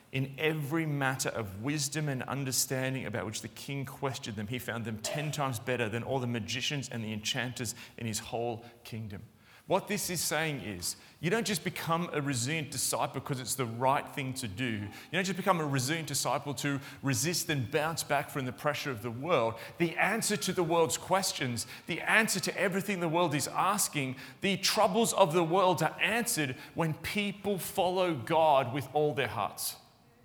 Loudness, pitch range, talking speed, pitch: -31 LUFS, 125-170 Hz, 190 wpm, 145 Hz